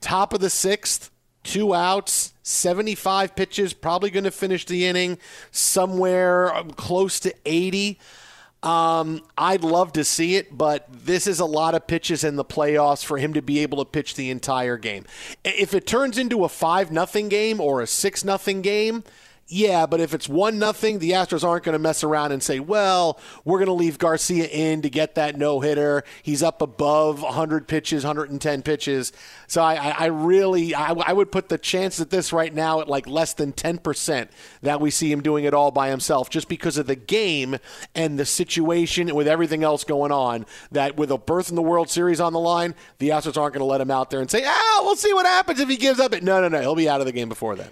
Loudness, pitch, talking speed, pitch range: -22 LUFS, 165 Hz, 225 wpm, 150-185 Hz